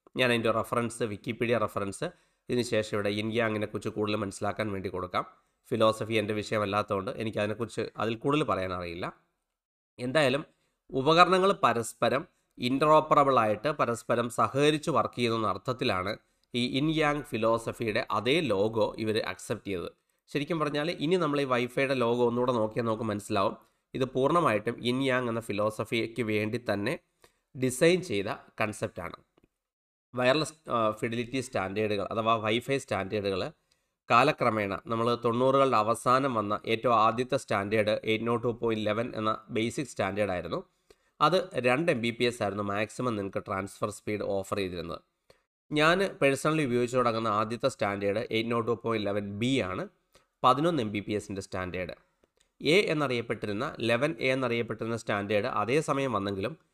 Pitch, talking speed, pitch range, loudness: 115 Hz, 130 wpm, 105-130 Hz, -29 LUFS